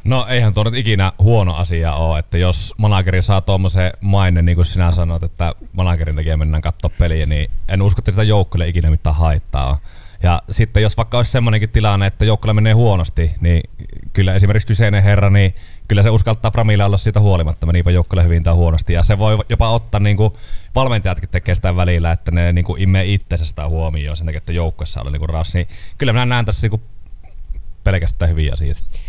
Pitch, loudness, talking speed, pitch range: 90 Hz, -16 LUFS, 200 wpm, 85-105 Hz